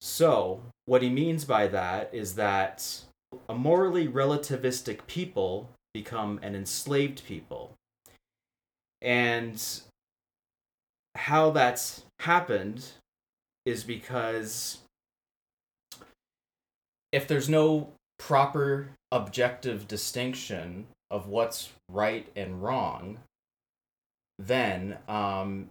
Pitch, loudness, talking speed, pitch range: 120 Hz, -29 LUFS, 80 wpm, 105-135 Hz